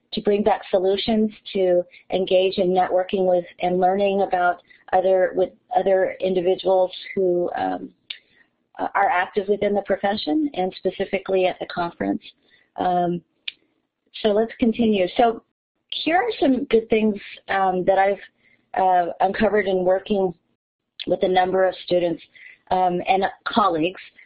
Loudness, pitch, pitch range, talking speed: -21 LUFS, 190 Hz, 180-205 Hz, 130 wpm